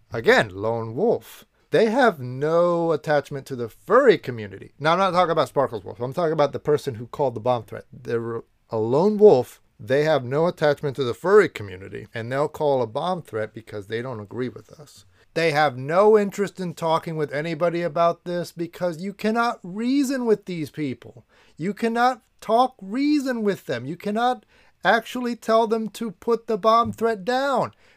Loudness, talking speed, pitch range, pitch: -22 LUFS, 185 wpm, 125-210 Hz, 165 Hz